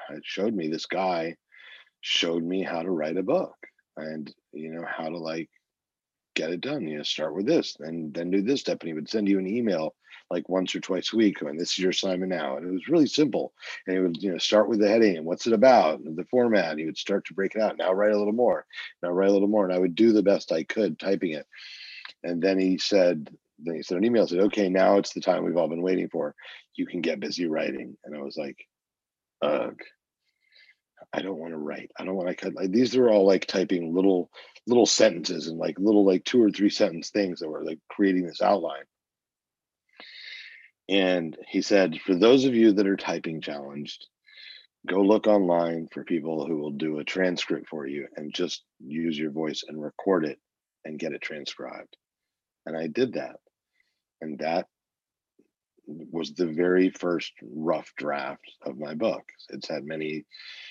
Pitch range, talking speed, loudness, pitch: 80-95 Hz, 215 wpm, -26 LUFS, 90 Hz